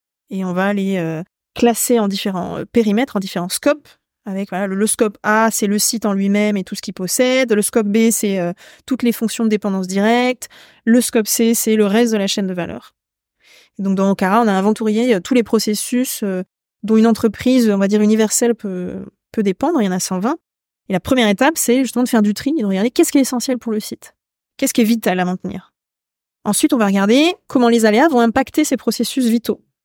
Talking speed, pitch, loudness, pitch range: 235 wpm, 220 Hz, -16 LUFS, 200-240 Hz